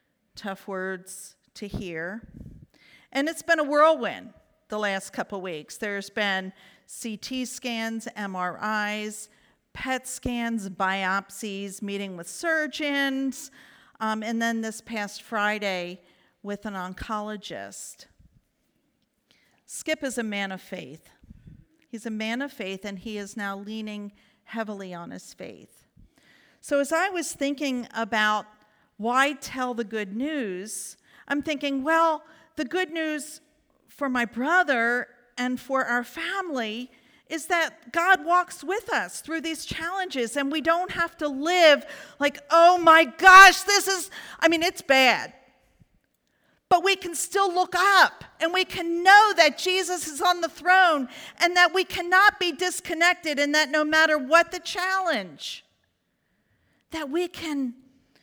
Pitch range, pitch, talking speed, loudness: 215-330 Hz, 275 Hz, 140 wpm, -23 LUFS